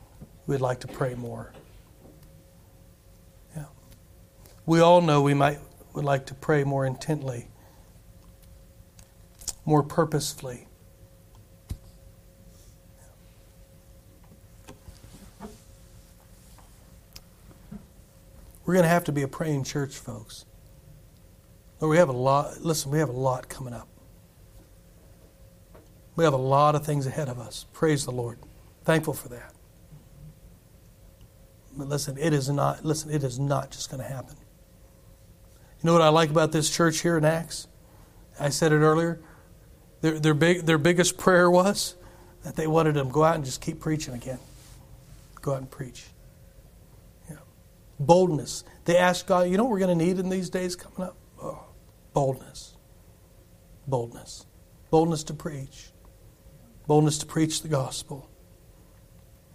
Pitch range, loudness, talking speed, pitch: 90-155 Hz, -25 LUFS, 135 wpm, 130 Hz